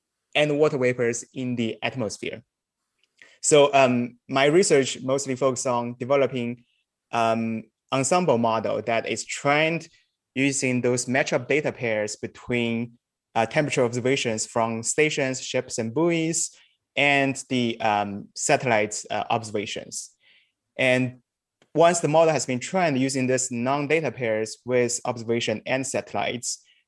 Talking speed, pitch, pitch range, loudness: 125 wpm, 125 Hz, 120-140 Hz, -24 LUFS